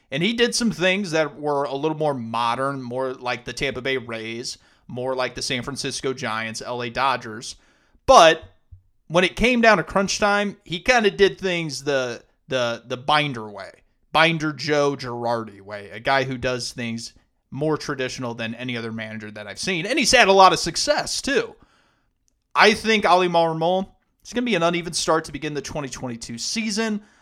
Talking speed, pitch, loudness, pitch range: 190 wpm, 140 Hz, -21 LUFS, 120-175 Hz